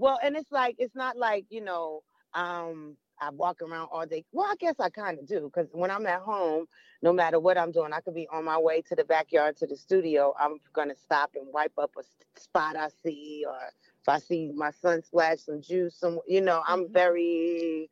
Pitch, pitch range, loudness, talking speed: 165 Hz, 155-180 Hz, -29 LUFS, 230 wpm